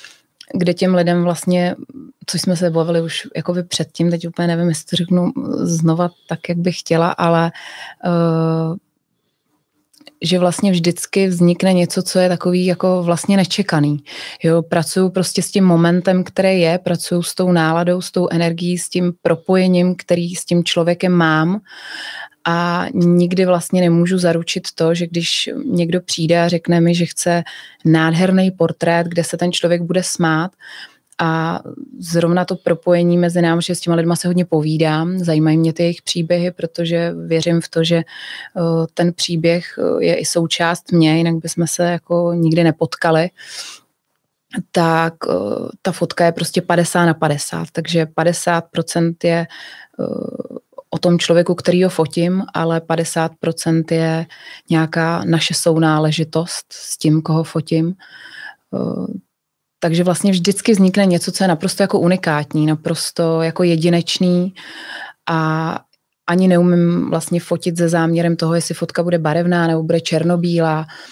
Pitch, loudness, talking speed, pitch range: 170 Hz, -16 LUFS, 145 wpm, 165-180 Hz